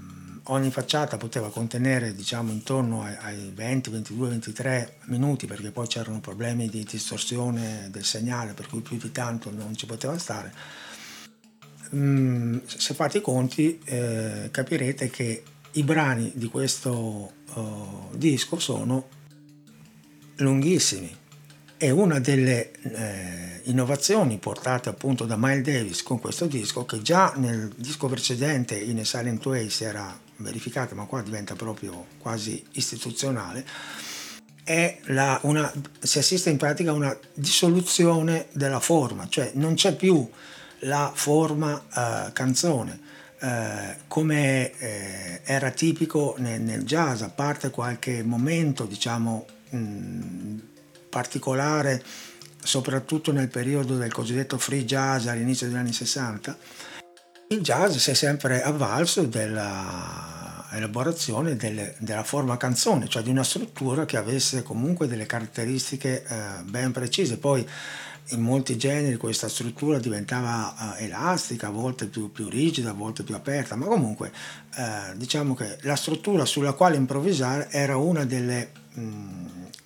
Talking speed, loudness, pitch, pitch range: 130 wpm, -26 LUFS, 125 Hz, 110-145 Hz